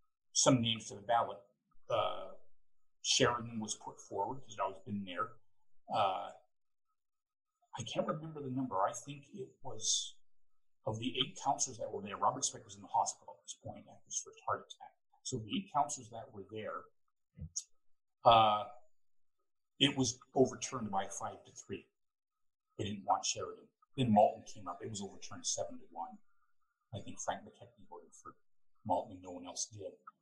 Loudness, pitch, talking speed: -36 LUFS, 135 Hz, 175 wpm